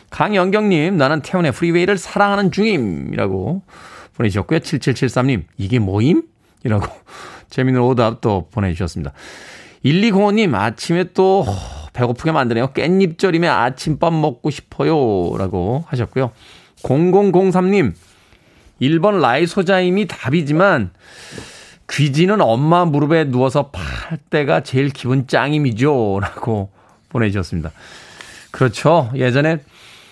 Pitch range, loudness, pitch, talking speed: 115-175 Hz, -17 LUFS, 140 Hz, 265 characters per minute